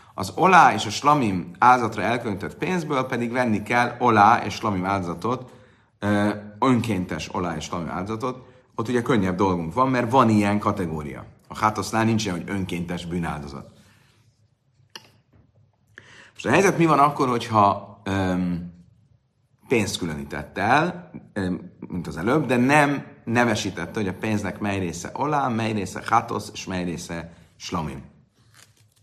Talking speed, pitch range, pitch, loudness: 135 wpm, 90-120 Hz, 105 Hz, -22 LUFS